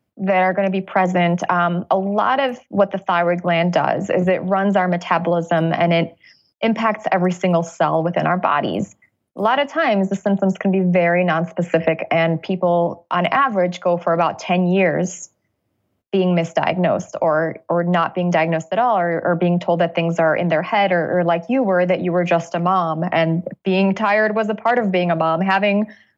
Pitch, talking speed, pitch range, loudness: 180 Hz, 205 wpm, 170-195 Hz, -18 LUFS